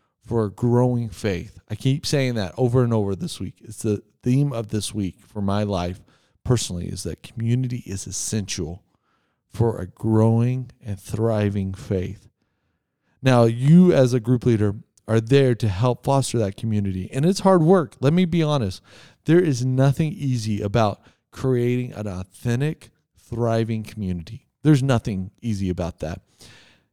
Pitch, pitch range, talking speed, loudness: 115 Hz, 100-125 Hz, 155 wpm, -22 LUFS